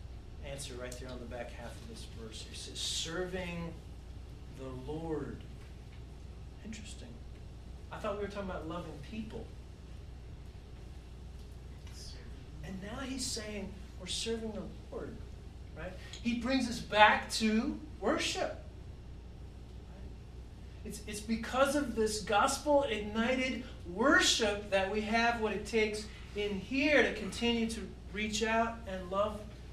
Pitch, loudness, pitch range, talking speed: 210 Hz, -34 LUFS, 140-230 Hz, 125 wpm